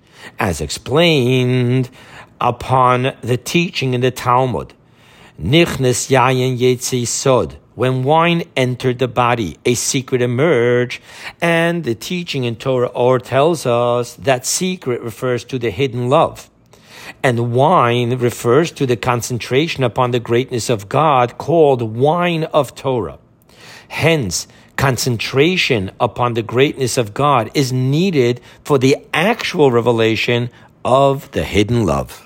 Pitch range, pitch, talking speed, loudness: 120-140 Hz, 125 Hz, 125 wpm, -16 LUFS